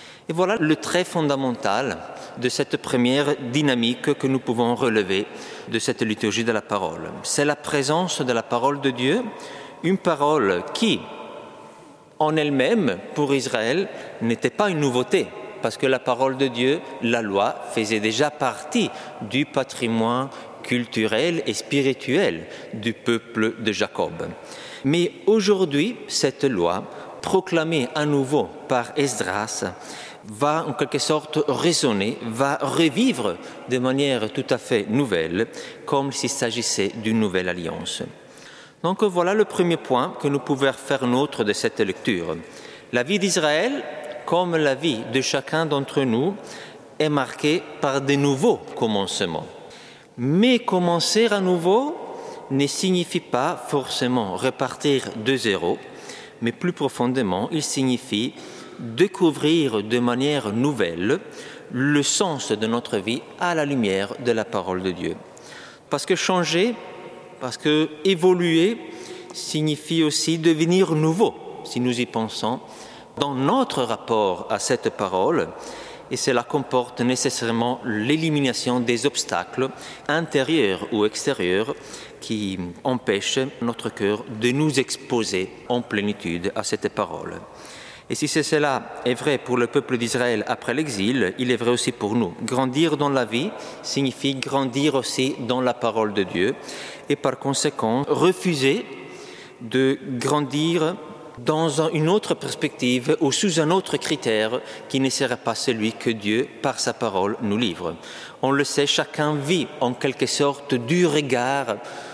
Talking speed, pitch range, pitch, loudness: 140 wpm, 120-155 Hz, 140 Hz, -22 LUFS